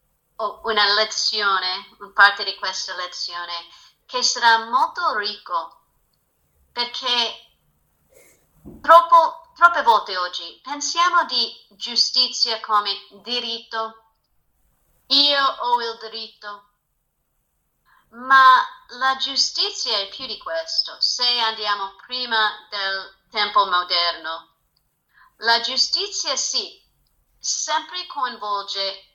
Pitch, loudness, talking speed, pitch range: 225 Hz, -19 LUFS, 90 wpm, 200-270 Hz